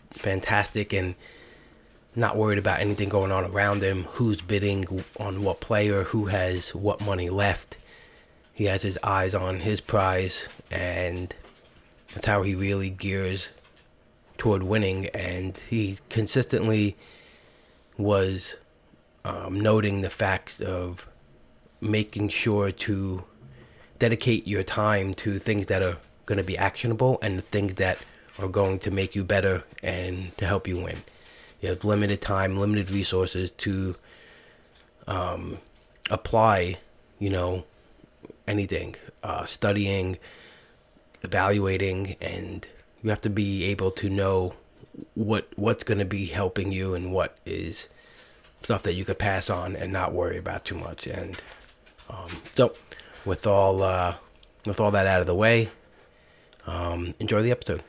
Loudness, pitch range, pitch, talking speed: -27 LUFS, 95-105 Hz, 100 Hz, 140 wpm